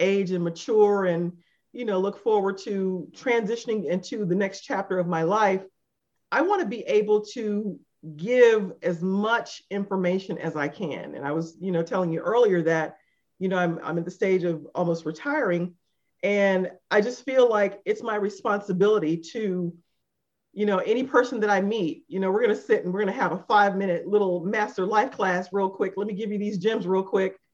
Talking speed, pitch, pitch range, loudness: 200 wpm, 195 Hz, 180-215 Hz, -25 LUFS